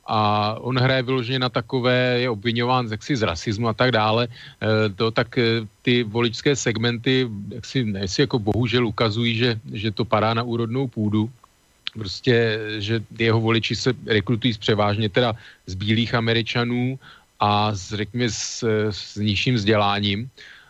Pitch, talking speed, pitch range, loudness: 115 Hz, 150 wpm, 110-125 Hz, -22 LUFS